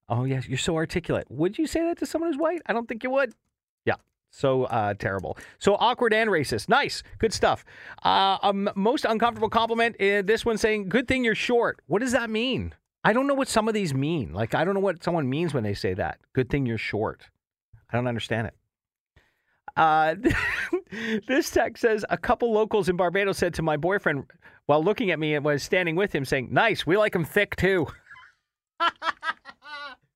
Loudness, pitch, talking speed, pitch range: -25 LUFS, 205 Hz, 205 wpm, 155-240 Hz